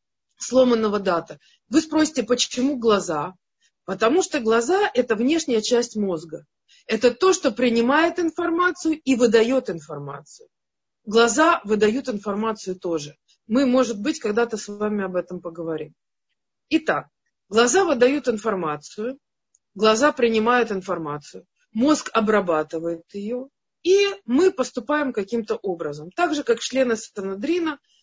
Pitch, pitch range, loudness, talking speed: 235 Hz, 195-285 Hz, -22 LUFS, 115 wpm